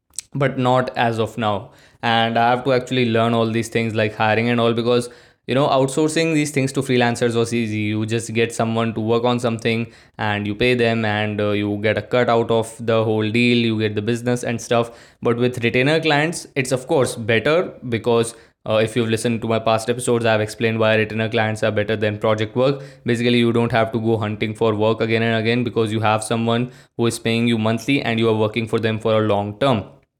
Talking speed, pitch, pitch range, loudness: 230 wpm, 115 Hz, 110-120 Hz, -19 LUFS